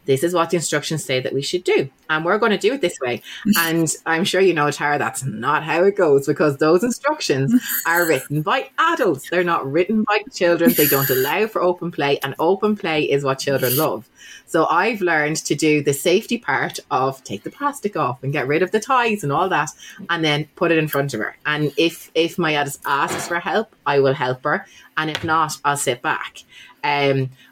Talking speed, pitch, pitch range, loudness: 225 wpm, 160 Hz, 145-185 Hz, -19 LUFS